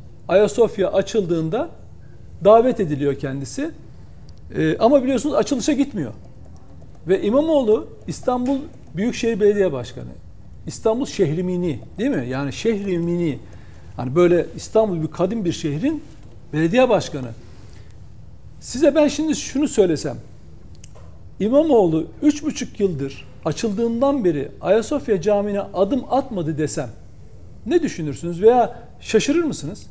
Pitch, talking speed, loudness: 185 Hz, 100 wpm, -20 LUFS